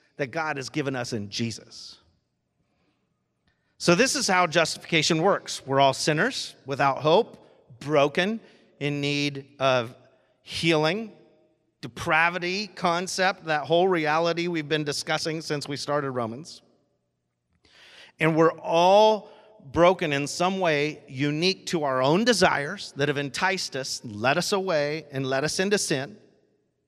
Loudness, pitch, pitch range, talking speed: -24 LUFS, 155 Hz, 140-180 Hz, 130 wpm